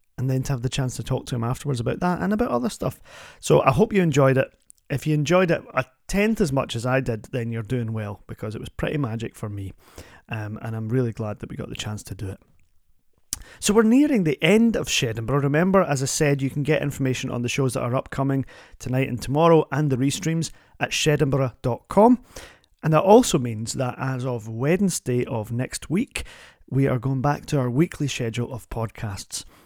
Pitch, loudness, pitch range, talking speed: 130 Hz, -23 LUFS, 115-150 Hz, 220 wpm